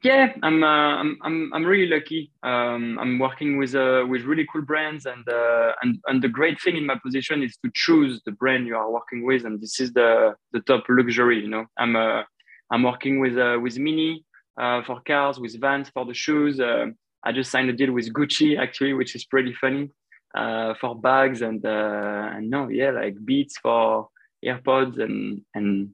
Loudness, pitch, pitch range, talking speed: -23 LUFS, 130 Hz, 120-150 Hz, 205 wpm